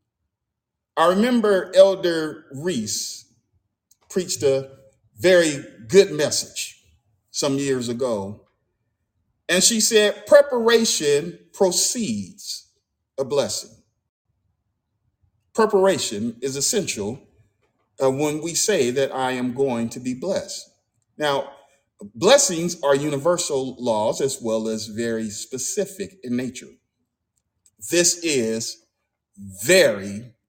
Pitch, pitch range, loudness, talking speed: 140 Hz, 115-180 Hz, -21 LUFS, 95 wpm